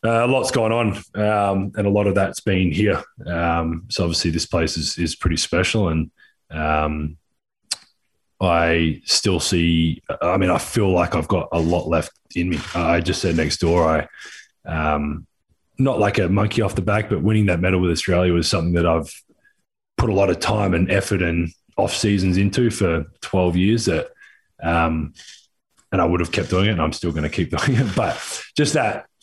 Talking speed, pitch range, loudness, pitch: 200 wpm, 85-100 Hz, -20 LUFS, 90 Hz